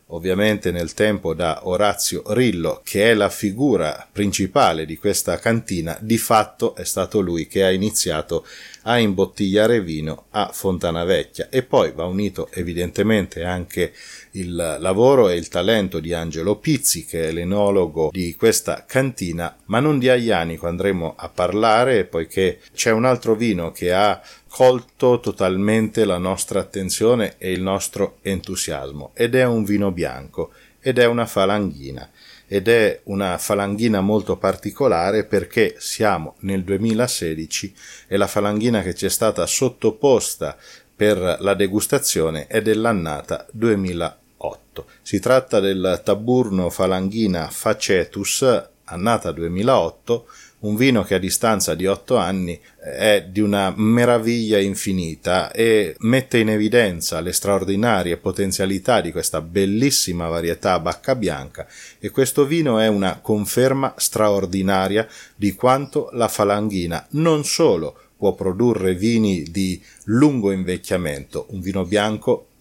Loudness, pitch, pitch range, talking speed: -19 LUFS, 100 Hz, 90-115 Hz, 130 wpm